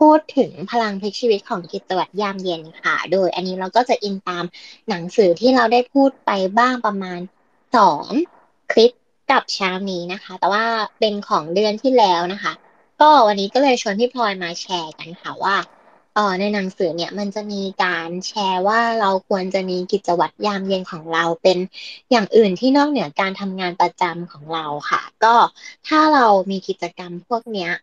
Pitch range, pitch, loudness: 180-230 Hz, 200 Hz, -18 LUFS